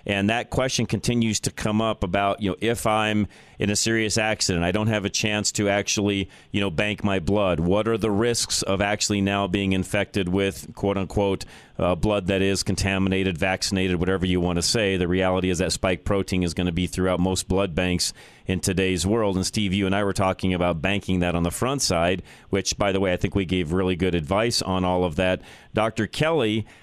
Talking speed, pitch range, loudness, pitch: 220 wpm, 95-105 Hz, -23 LUFS, 95 Hz